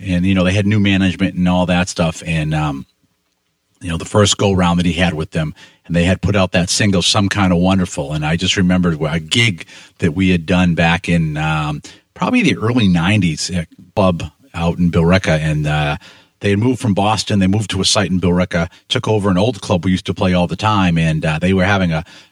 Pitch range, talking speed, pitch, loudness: 85-100 Hz, 235 wpm, 90 Hz, -15 LUFS